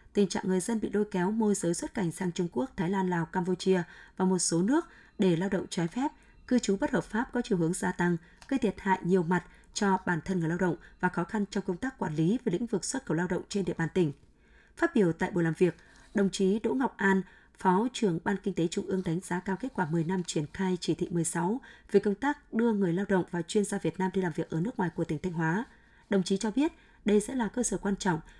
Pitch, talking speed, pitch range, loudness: 190 Hz, 275 wpm, 175-215 Hz, -30 LUFS